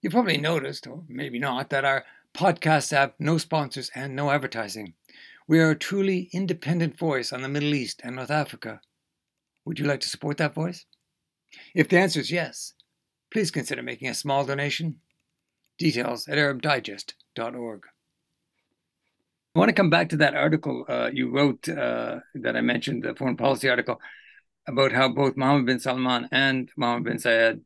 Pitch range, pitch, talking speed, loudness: 125-155 Hz, 140 Hz, 170 wpm, -25 LUFS